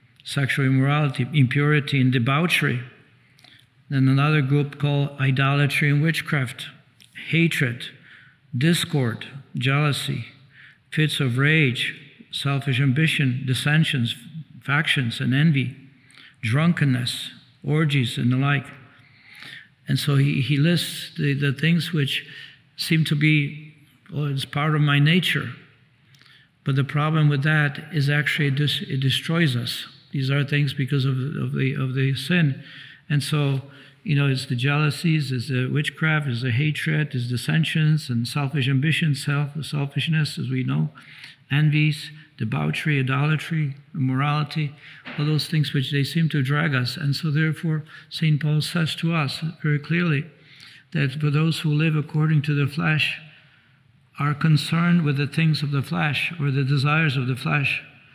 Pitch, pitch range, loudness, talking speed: 145 Hz, 135-155 Hz, -22 LUFS, 140 wpm